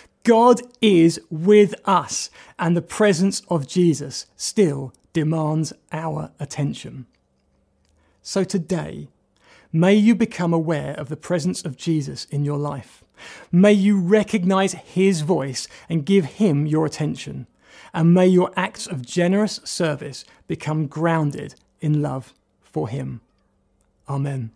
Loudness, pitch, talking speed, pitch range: -20 LUFS, 165 Hz, 125 wpm, 145-190 Hz